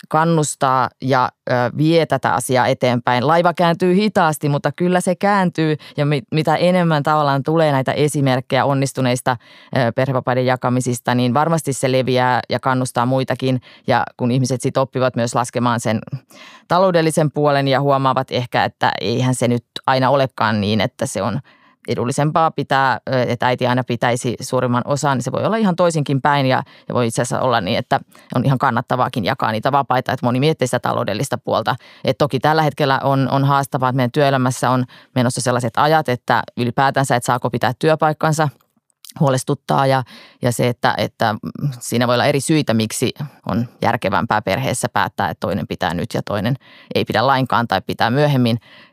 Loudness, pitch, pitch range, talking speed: -18 LUFS, 130 Hz, 125-150 Hz, 165 wpm